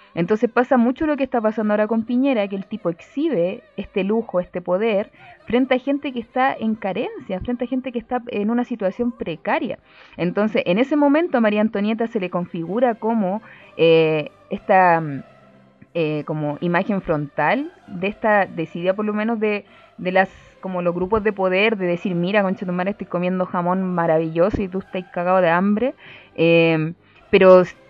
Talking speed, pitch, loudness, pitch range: 175 wpm, 200 Hz, -20 LUFS, 175-235 Hz